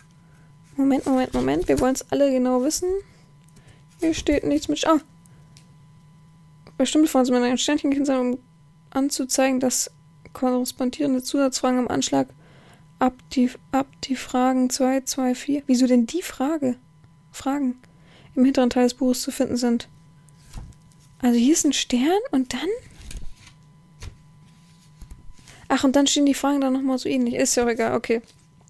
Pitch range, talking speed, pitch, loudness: 165-270 Hz, 155 wpm, 250 Hz, -22 LUFS